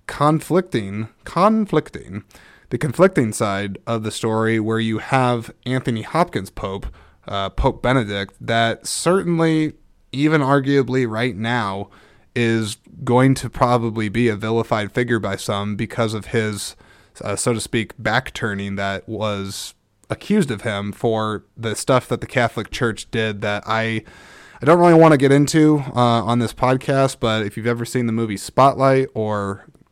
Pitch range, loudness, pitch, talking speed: 110-135 Hz, -19 LUFS, 115 Hz, 150 wpm